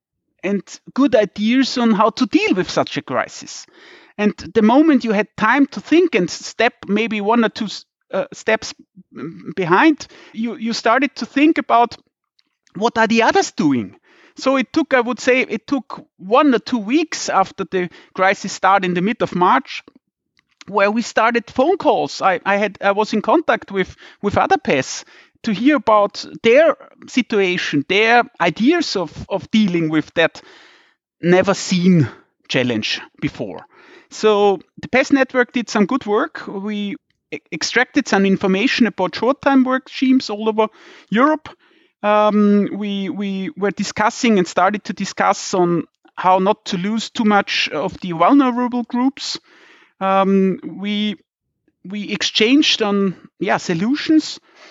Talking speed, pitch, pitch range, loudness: 150 wpm, 220 Hz, 195-265 Hz, -17 LUFS